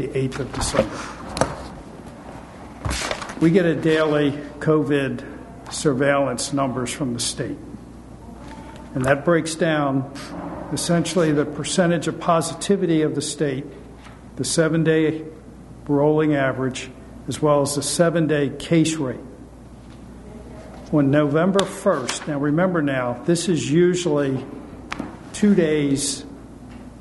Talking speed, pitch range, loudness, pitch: 105 wpm, 140-165 Hz, -21 LUFS, 150 Hz